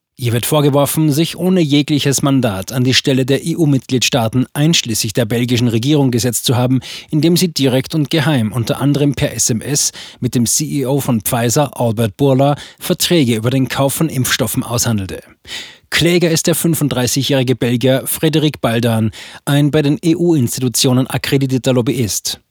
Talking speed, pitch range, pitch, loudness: 145 wpm, 125-150 Hz, 135 Hz, -14 LUFS